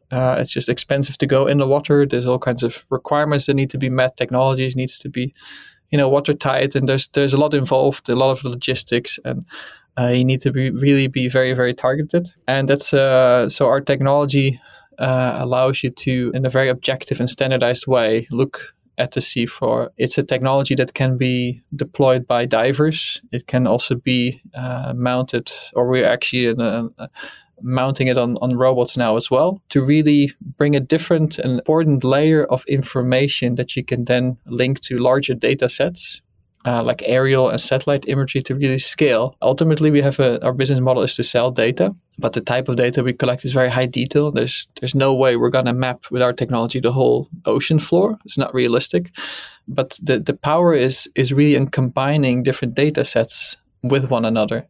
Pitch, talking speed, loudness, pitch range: 130 Hz, 200 wpm, -18 LUFS, 125-140 Hz